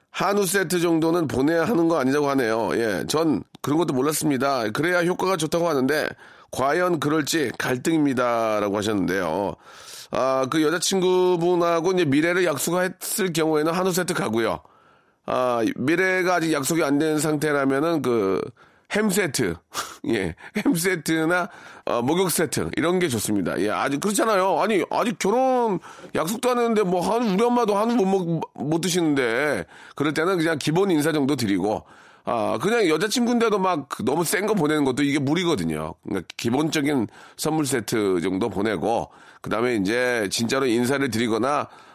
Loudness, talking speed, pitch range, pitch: -22 LUFS, 340 characters per minute, 140-185 Hz, 165 Hz